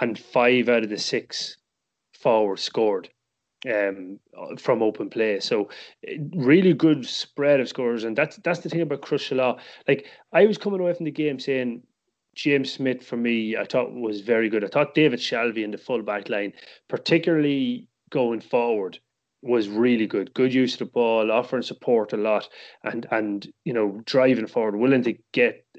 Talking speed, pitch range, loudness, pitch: 180 wpm, 115-155 Hz, -23 LUFS, 125 Hz